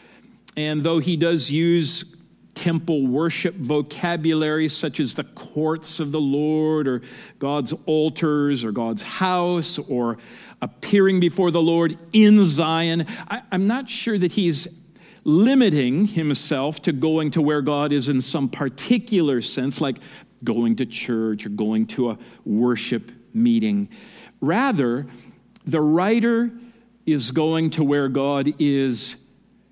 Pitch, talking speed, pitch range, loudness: 155 Hz, 130 wpm, 140-180 Hz, -21 LUFS